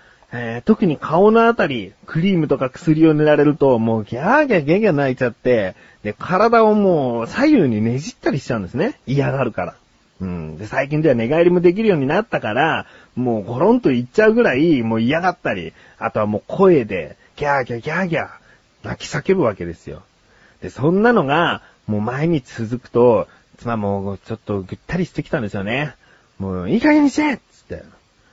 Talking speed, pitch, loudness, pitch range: 390 characters per minute, 135 Hz, -18 LUFS, 115-180 Hz